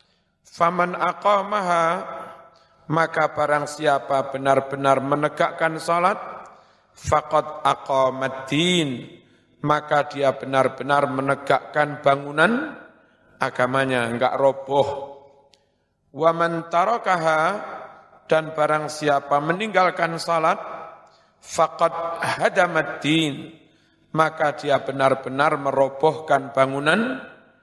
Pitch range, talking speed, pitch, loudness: 140-165 Hz, 70 wpm, 150 Hz, -21 LUFS